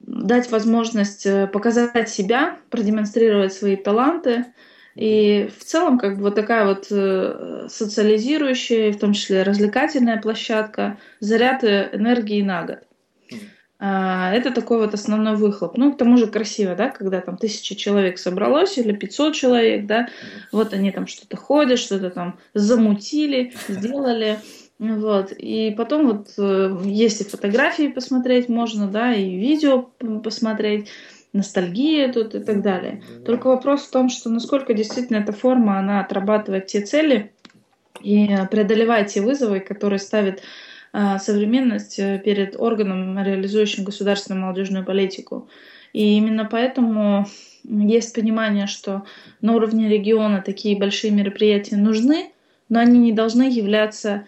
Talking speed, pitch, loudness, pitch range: 130 wpm, 215 Hz, -19 LUFS, 200-235 Hz